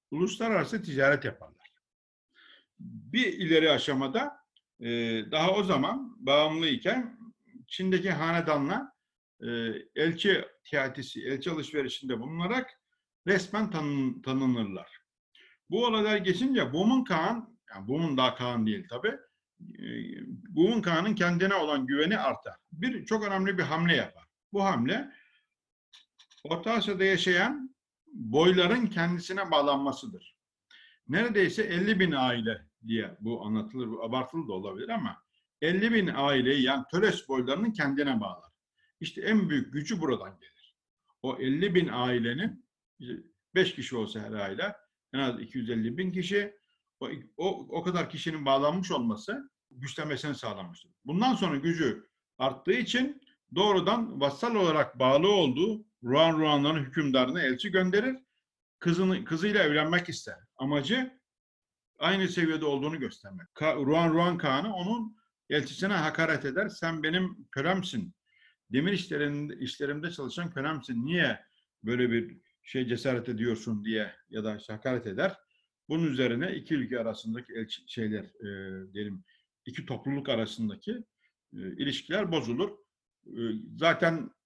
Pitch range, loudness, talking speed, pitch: 135-205 Hz, -29 LUFS, 120 wpm, 165 Hz